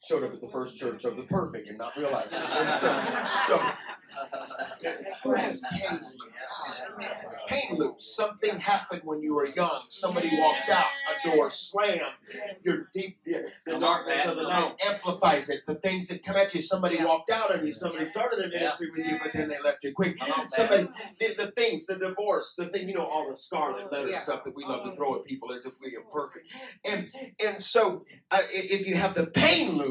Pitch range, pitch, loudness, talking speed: 160-205 Hz, 190 Hz, -28 LUFS, 205 wpm